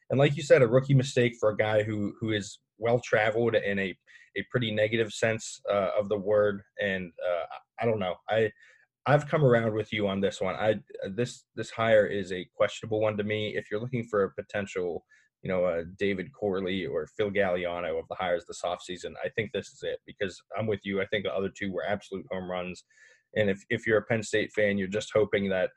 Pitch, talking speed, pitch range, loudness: 105 Hz, 230 wpm, 100-120 Hz, -29 LUFS